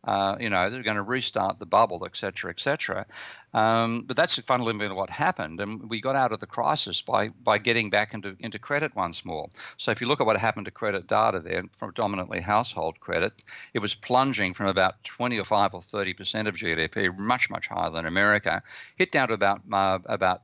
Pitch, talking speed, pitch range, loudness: 105 Hz, 210 wpm, 95-115 Hz, -26 LUFS